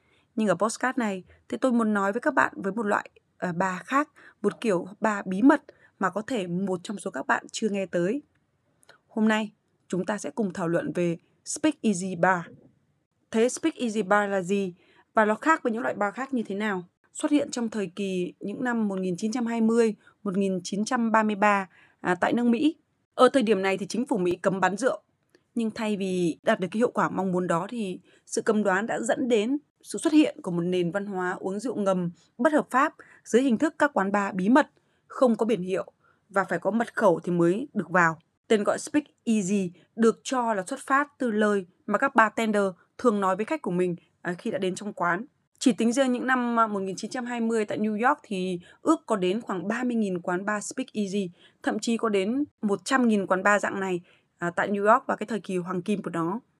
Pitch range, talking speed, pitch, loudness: 185-240 Hz, 215 wpm, 210 Hz, -26 LUFS